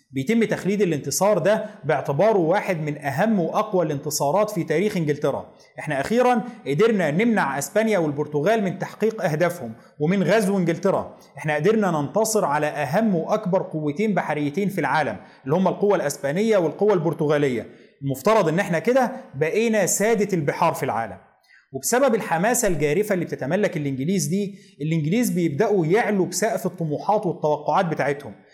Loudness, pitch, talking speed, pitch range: -22 LUFS, 180 Hz, 135 wpm, 150-210 Hz